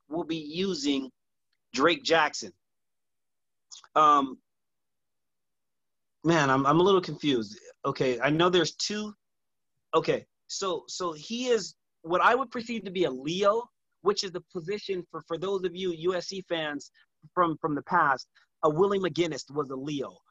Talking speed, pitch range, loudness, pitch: 150 wpm, 155-195 Hz, -28 LUFS, 180 Hz